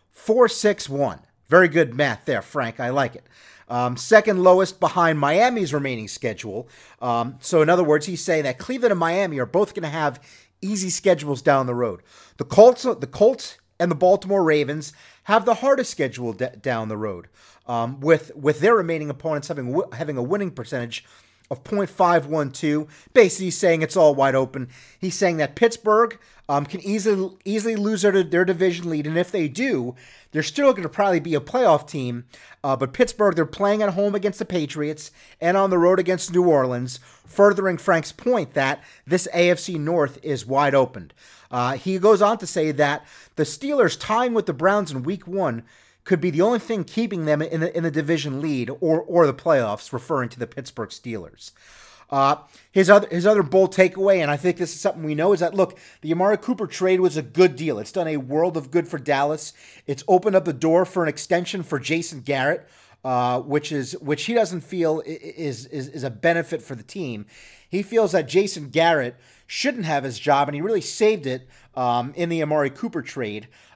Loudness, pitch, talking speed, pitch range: -21 LUFS, 165 Hz, 200 wpm, 140-190 Hz